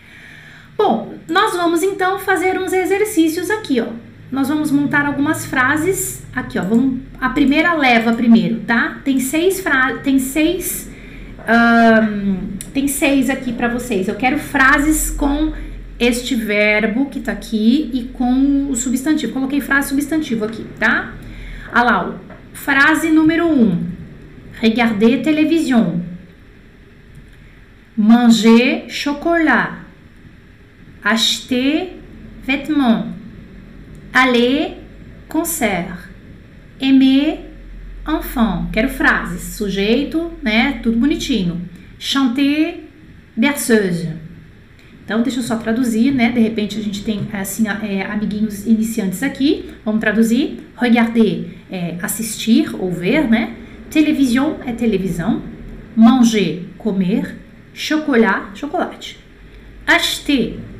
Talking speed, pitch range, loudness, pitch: 105 wpm, 215-290 Hz, -16 LUFS, 245 Hz